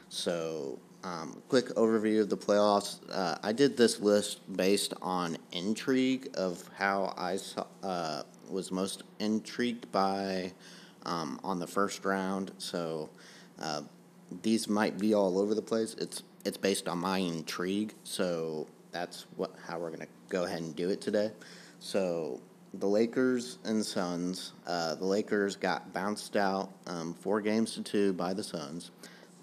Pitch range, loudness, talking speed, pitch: 90-105 Hz, -33 LUFS, 155 wpm, 100 Hz